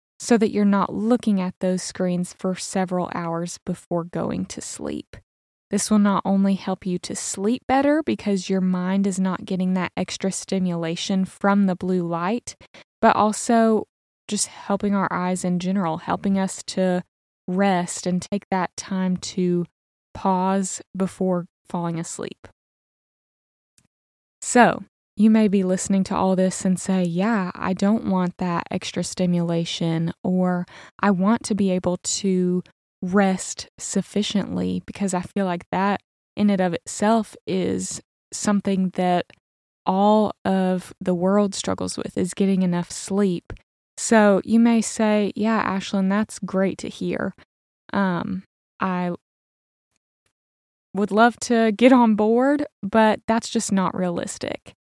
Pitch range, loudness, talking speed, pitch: 180-205 Hz, -22 LUFS, 140 wpm, 190 Hz